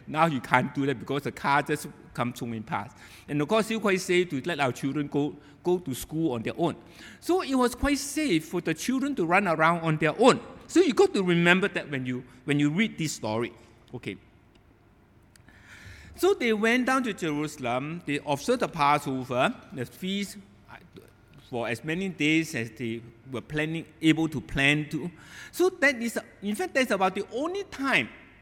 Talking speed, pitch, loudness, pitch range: 195 wpm, 155 Hz, -27 LUFS, 125-195 Hz